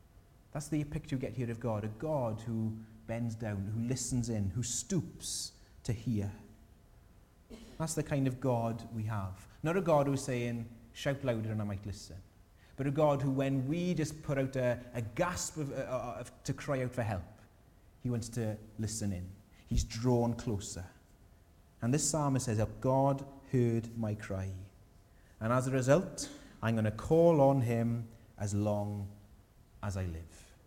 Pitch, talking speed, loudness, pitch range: 115 Hz, 175 wpm, -34 LUFS, 105-135 Hz